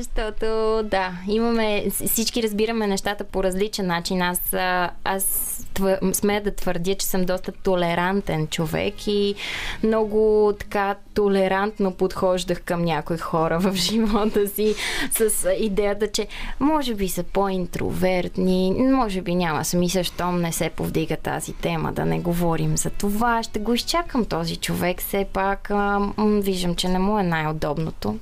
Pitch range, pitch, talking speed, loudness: 180-210 Hz, 195 Hz, 140 wpm, -23 LUFS